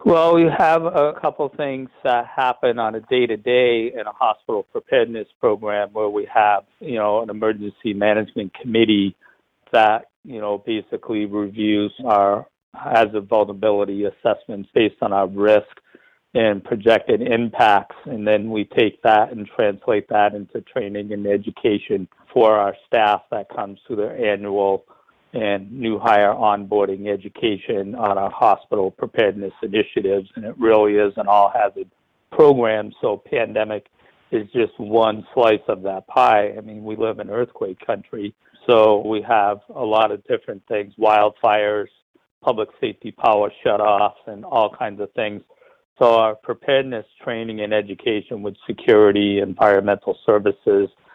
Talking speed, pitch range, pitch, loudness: 150 wpm, 100-115 Hz, 105 Hz, -19 LUFS